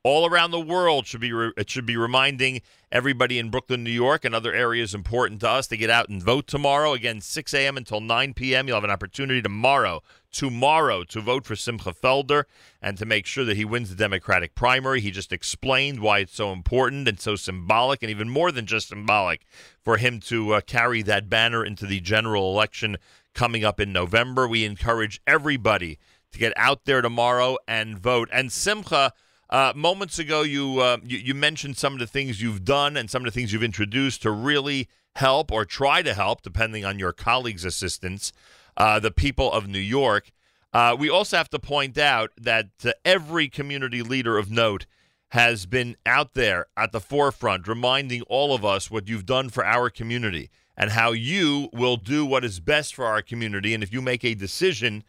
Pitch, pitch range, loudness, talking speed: 120 Hz, 105-130 Hz, -23 LUFS, 200 wpm